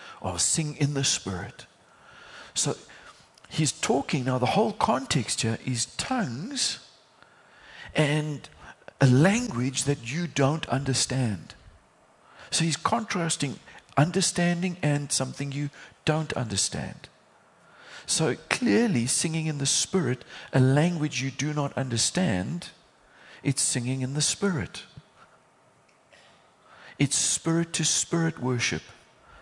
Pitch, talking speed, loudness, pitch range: 145 Hz, 110 wpm, -26 LUFS, 130-165 Hz